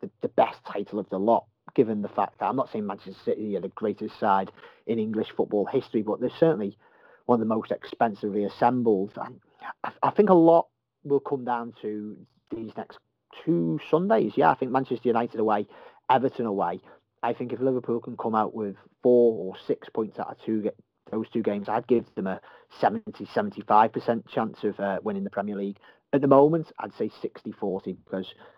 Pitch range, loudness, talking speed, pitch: 105-125 Hz, -26 LUFS, 190 wpm, 110 Hz